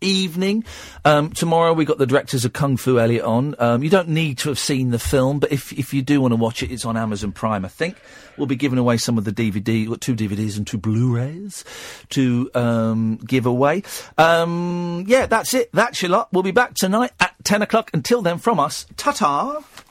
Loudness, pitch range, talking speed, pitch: -19 LUFS, 120-180 Hz, 220 wpm, 140 Hz